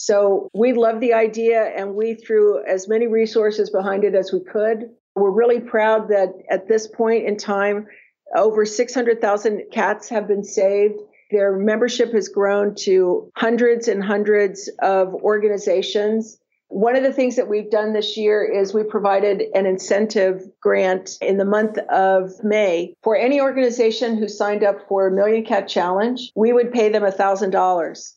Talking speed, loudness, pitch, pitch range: 165 wpm, -19 LUFS, 210 Hz, 200-225 Hz